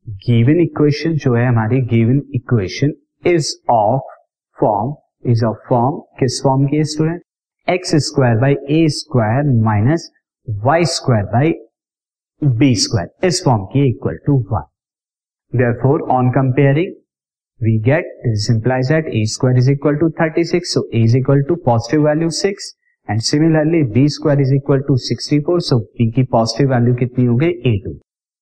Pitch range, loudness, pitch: 120-155 Hz, -16 LUFS, 135 Hz